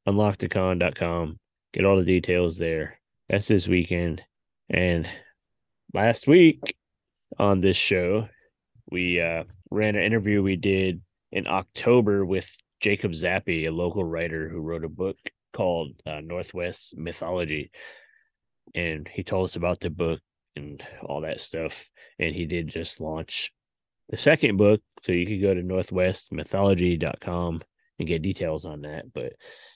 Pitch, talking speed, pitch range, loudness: 90 Hz, 140 wpm, 85-100 Hz, -25 LUFS